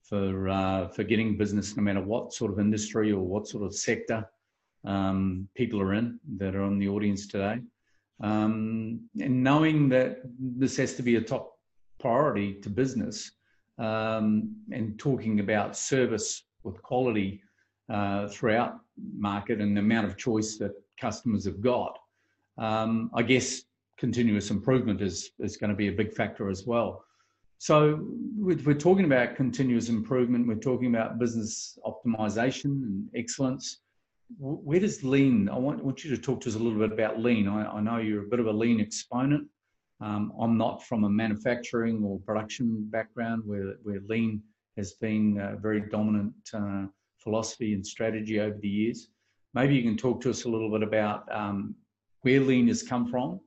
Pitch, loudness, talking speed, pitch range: 110 Hz, -28 LUFS, 170 wpm, 105-125 Hz